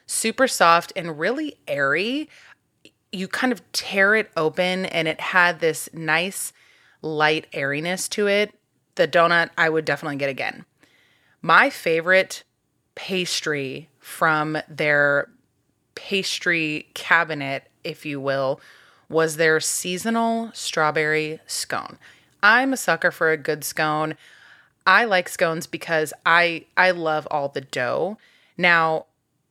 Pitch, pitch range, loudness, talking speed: 165 Hz, 155-185 Hz, -21 LUFS, 120 wpm